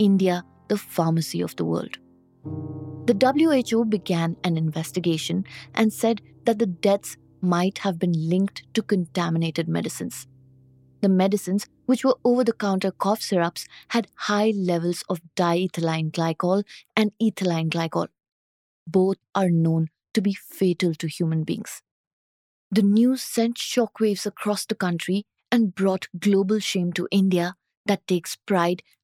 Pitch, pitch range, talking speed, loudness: 185 Hz, 165-210 Hz, 135 wpm, -24 LUFS